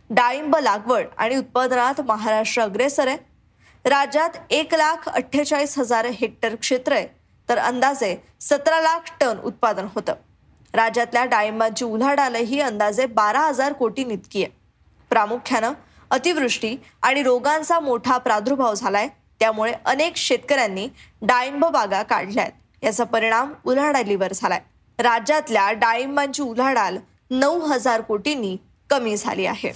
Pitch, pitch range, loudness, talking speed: 250 Hz, 225-285 Hz, -21 LUFS, 115 wpm